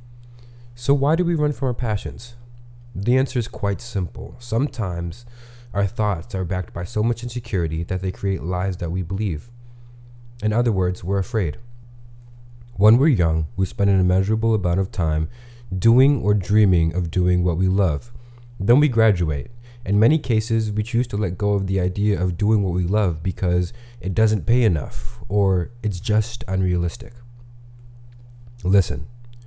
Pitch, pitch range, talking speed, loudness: 105 Hz, 95-120 Hz, 165 wpm, -21 LUFS